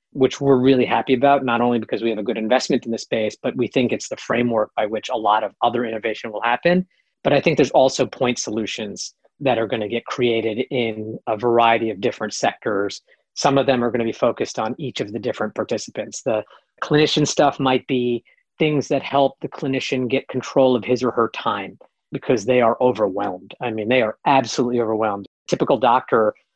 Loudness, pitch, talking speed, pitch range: -20 LUFS, 125 Hz, 210 wpm, 115-135 Hz